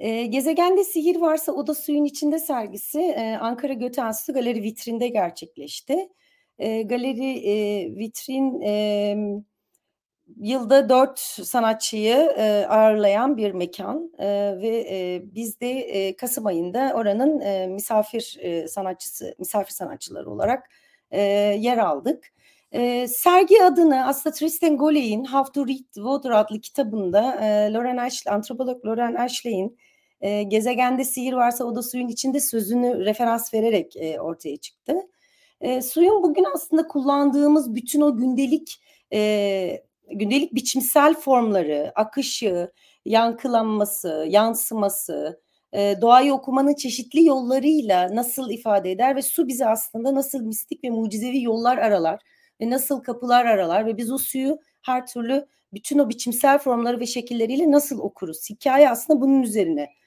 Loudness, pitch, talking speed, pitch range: -22 LUFS, 245 Hz, 120 wpm, 210-275 Hz